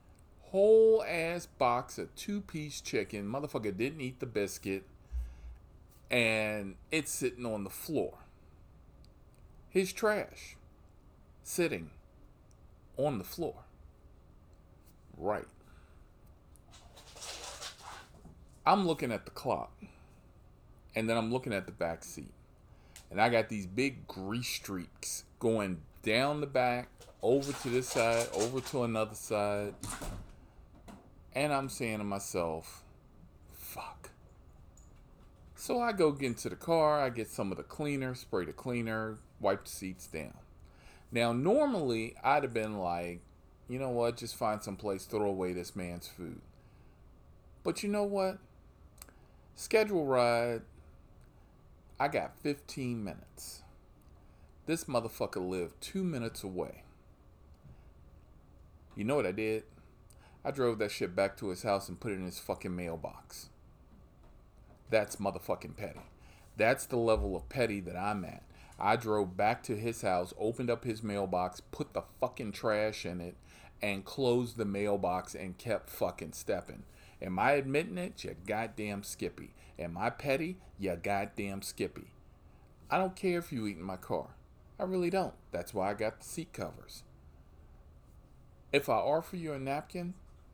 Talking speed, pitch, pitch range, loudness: 140 wpm, 105 Hz, 90-125 Hz, -34 LUFS